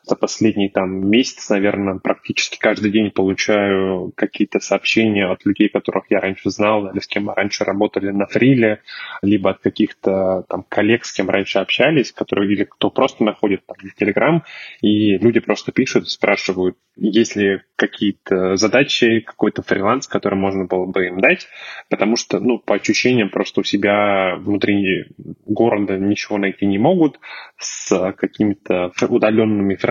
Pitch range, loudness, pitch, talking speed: 95-110 Hz, -17 LUFS, 100 Hz, 155 wpm